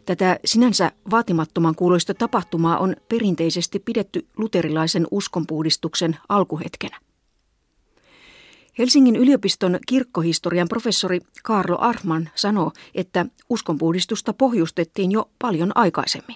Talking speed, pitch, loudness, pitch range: 90 wpm, 185 Hz, -20 LUFS, 170-225 Hz